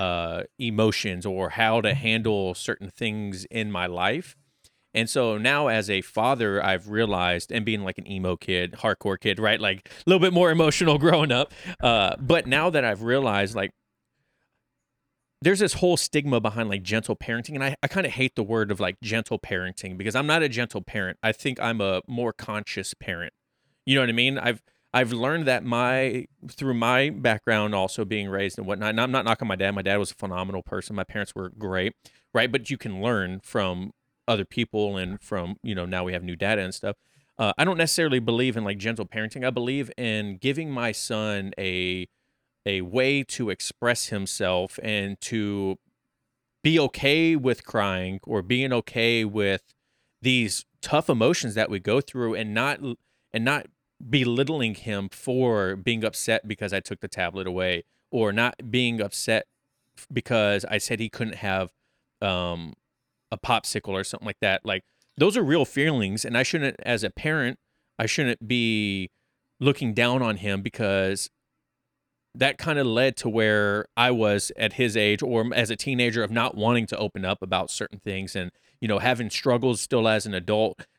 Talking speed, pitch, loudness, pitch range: 185 wpm, 110 Hz, -25 LUFS, 100-125 Hz